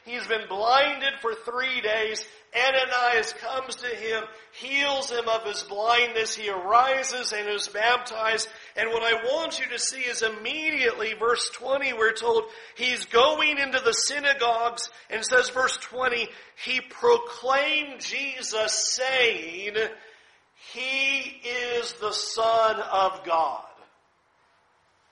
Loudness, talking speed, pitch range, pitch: -25 LUFS, 125 wpm, 220-270 Hz, 240 Hz